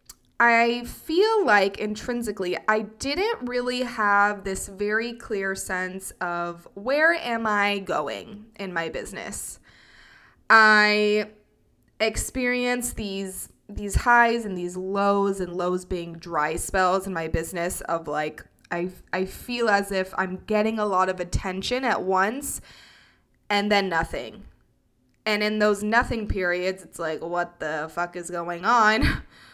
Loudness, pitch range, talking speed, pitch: -24 LUFS, 180-220 Hz, 135 wpm, 200 Hz